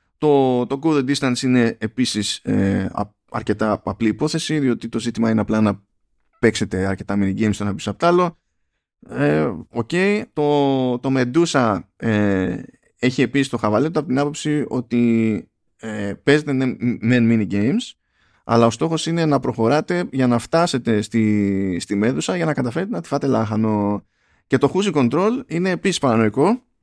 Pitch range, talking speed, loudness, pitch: 105-145 Hz, 155 wpm, -20 LUFS, 120 Hz